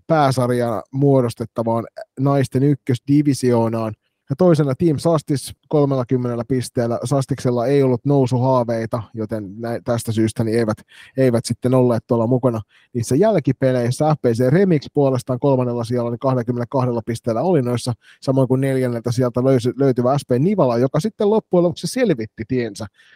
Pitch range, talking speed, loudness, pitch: 120-140 Hz, 130 wpm, -19 LUFS, 125 Hz